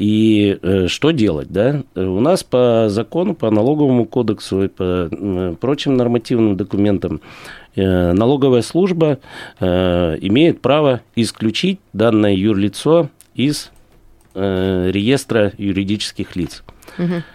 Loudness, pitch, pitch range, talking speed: -16 LUFS, 110 Hz, 95-130 Hz, 95 wpm